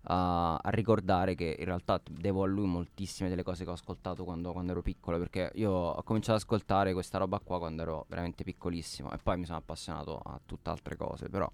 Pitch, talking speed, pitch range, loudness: 90 Hz, 220 wpm, 85-95 Hz, -34 LUFS